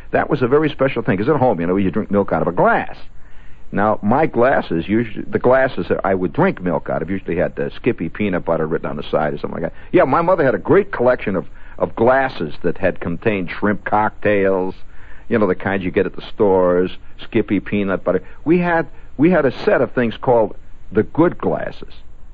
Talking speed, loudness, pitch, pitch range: 225 wpm, -18 LUFS, 100 Hz, 90-125 Hz